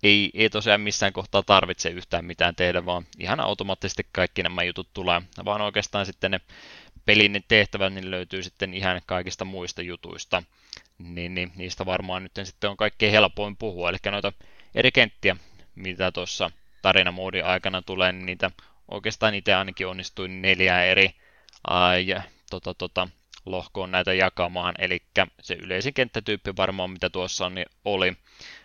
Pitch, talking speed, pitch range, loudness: 95 Hz, 150 wpm, 90-100 Hz, -24 LUFS